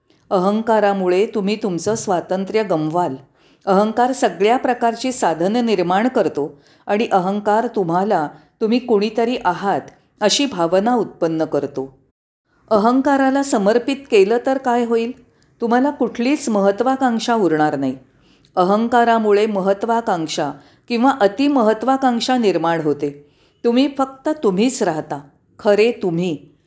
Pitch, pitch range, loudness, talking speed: 210 Hz, 170-240 Hz, -18 LUFS, 100 wpm